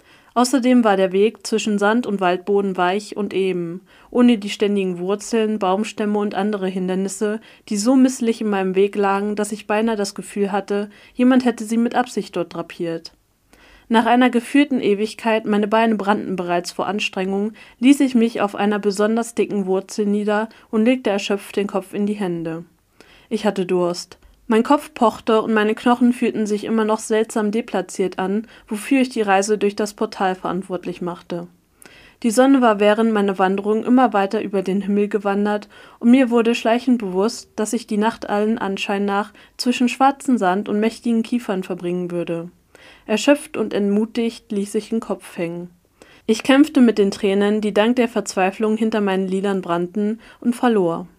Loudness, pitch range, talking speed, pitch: -19 LUFS, 195-230 Hz, 170 wpm, 210 Hz